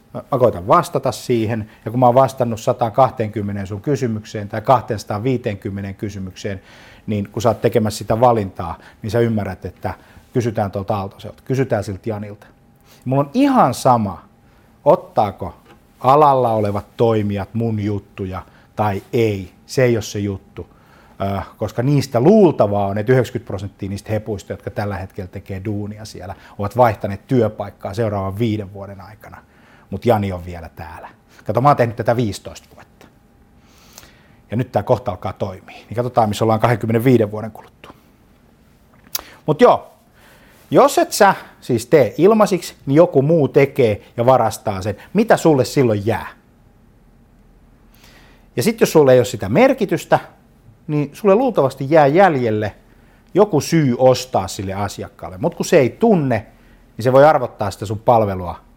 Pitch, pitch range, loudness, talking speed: 115 Hz, 100-130 Hz, -17 LUFS, 150 wpm